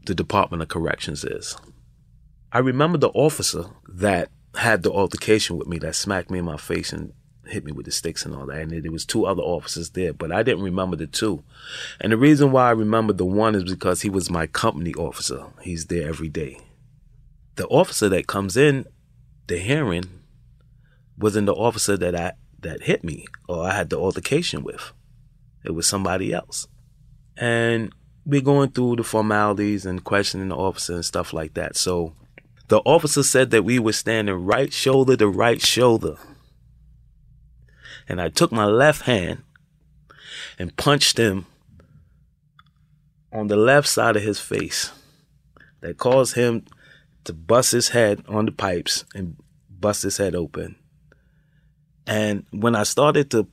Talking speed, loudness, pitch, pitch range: 170 wpm, -21 LUFS, 110 Hz, 95-135 Hz